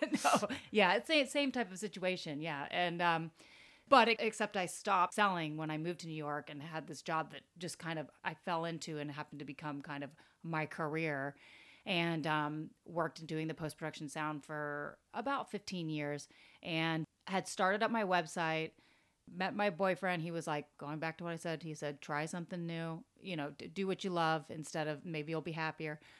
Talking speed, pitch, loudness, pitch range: 205 wpm, 160 Hz, -37 LUFS, 155-185 Hz